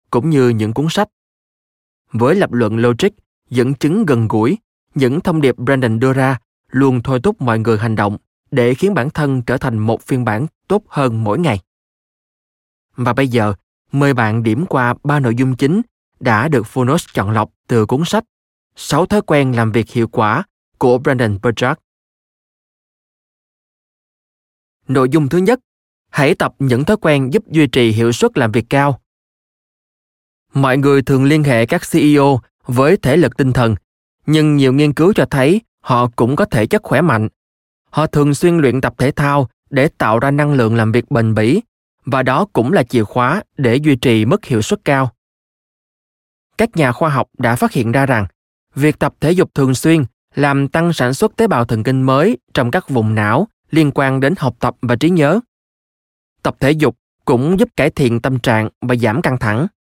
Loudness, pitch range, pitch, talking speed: -15 LUFS, 115-150 Hz, 130 Hz, 190 wpm